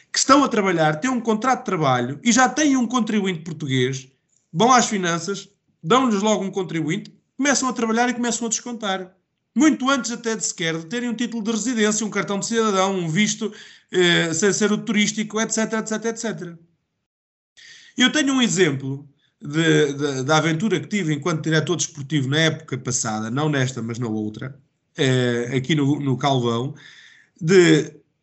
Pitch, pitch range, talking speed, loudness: 190 Hz, 150-225 Hz, 165 wpm, -20 LUFS